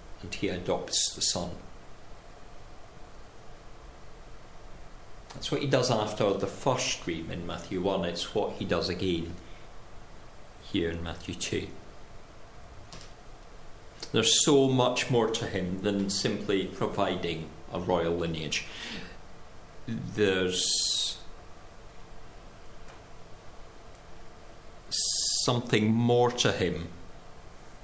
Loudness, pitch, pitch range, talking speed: -28 LUFS, 95 Hz, 85-115 Hz, 90 wpm